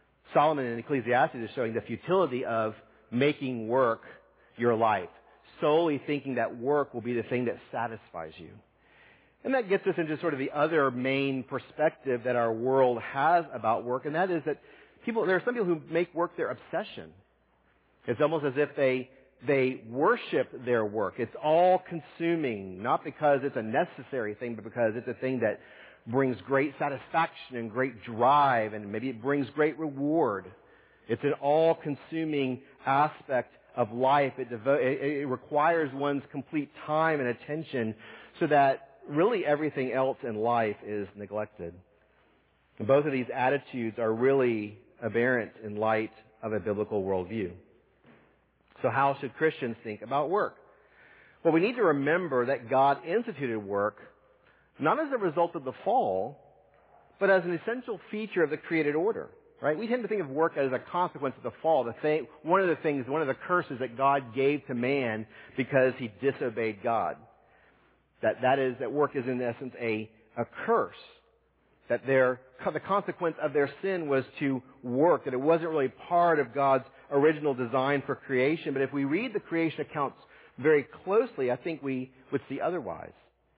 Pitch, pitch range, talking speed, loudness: 135 Hz, 125-155 Hz, 170 wpm, -29 LUFS